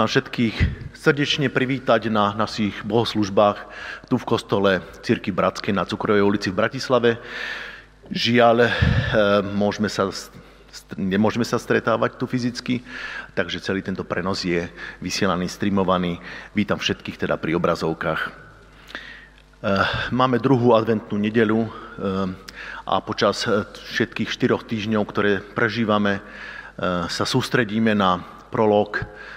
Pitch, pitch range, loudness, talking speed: 105 Hz, 100-120 Hz, -22 LUFS, 100 wpm